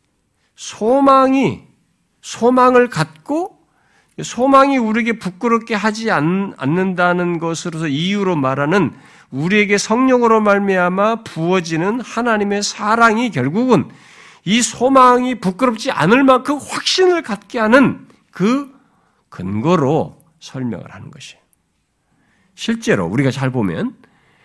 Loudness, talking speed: -15 LUFS, 250 characters per minute